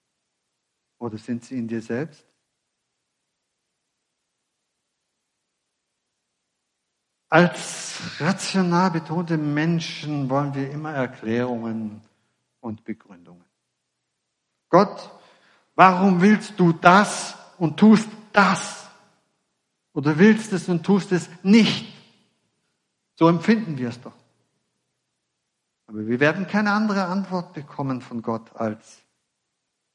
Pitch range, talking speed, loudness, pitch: 120-195 Hz, 95 wpm, -21 LUFS, 165 Hz